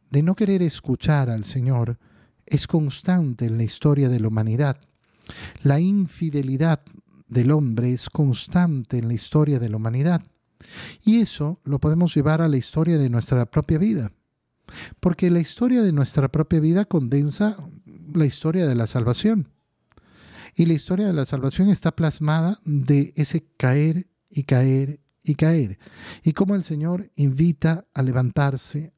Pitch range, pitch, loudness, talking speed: 130-170 Hz, 150 Hz, -21 LUFS, 150 wpm